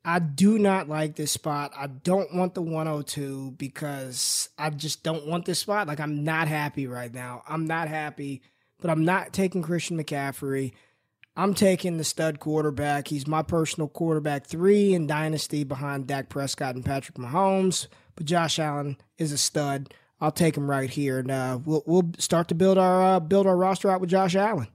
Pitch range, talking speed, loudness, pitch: 140-175 Hz, 190 wpm, -26 LUFS, 155 Hz